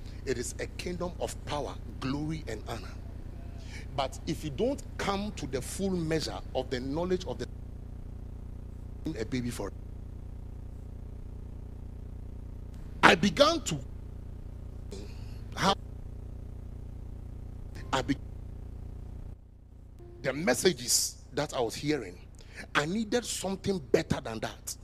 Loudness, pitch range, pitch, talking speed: -31 LUFS, 95-135 Hz, 105 Hz, 100 wpm